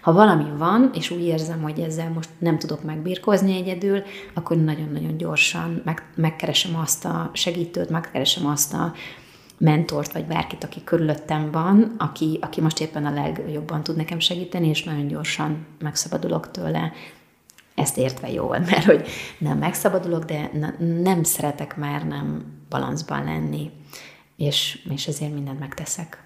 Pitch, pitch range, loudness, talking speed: 155 Hz, 145-170 Hz, -23 LUFS, 145 wpm